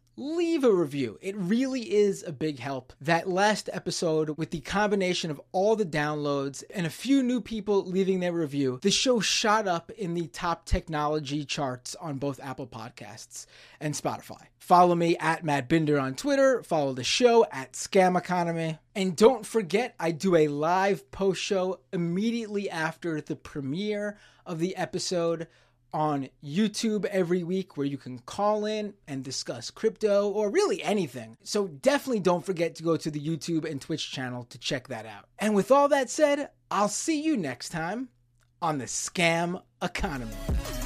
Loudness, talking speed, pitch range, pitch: -27 LUFS, 170 wpm, 145-205 Hz, 175 Hz